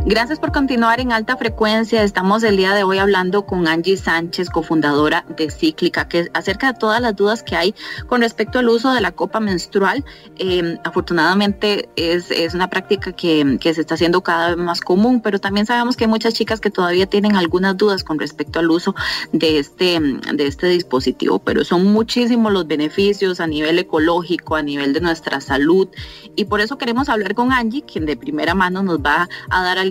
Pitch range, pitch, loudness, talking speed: 170-220 Hz, 190 Hz, -17 LUFS, 200 wpm